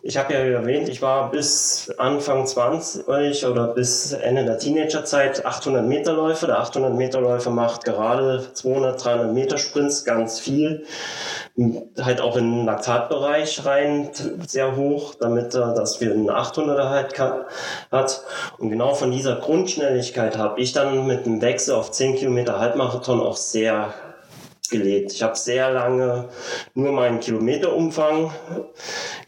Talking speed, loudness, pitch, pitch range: 140 wpm, -21 LUFS, 130 Hz, 120-145 Hz